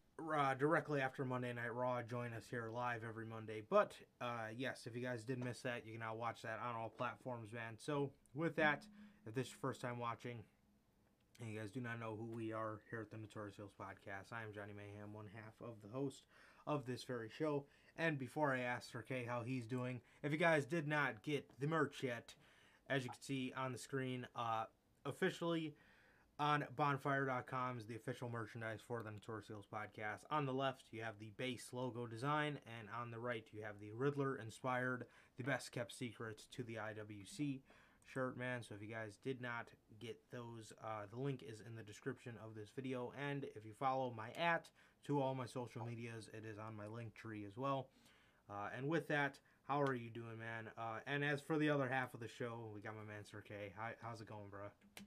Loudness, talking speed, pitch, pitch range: -45 LUFS, 220 wpm, 120 Hz, 110-135 Hz